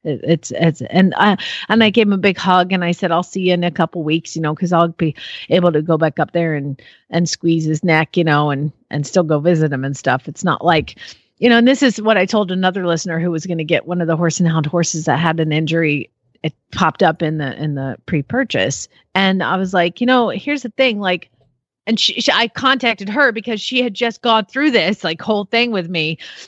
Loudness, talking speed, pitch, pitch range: -16 LUFS, 255 wpm, 175 Hz, 160-210 Hz